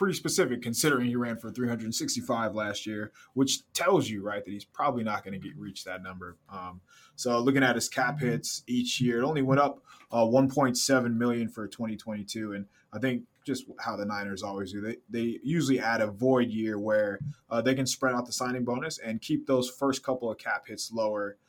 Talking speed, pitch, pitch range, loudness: 215 wpm, 120 Hz, 110-130 Hz, -29 LUFS